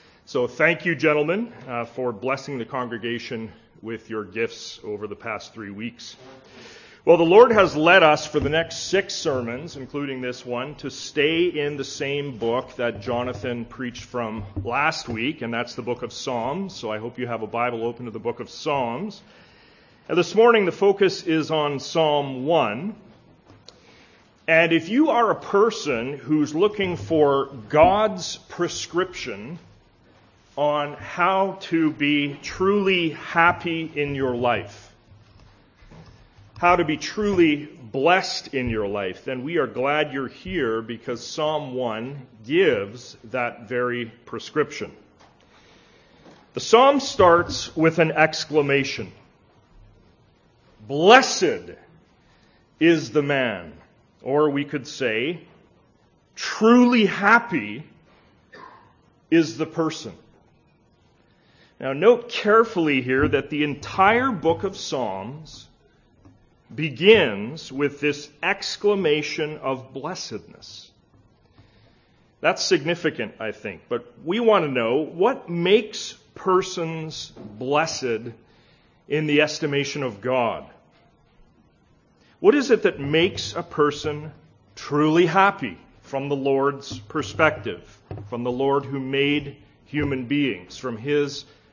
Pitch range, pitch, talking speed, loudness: 120-165 Hz, 145 Hz, 120 wpm, -22 LUFS